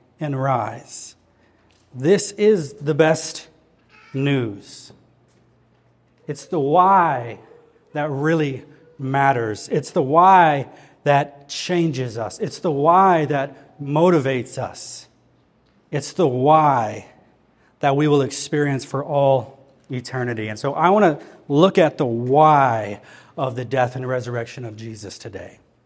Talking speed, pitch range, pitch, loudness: 120 wpm, 125-150 Hz, 135 Hz, -19 LUFS